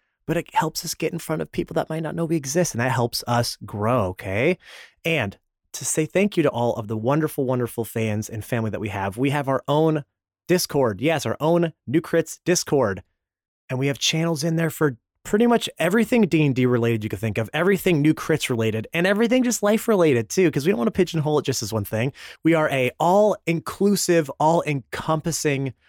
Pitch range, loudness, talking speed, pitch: 115-165 Hz, -22 LUFS, 220 wpm, 150 Hz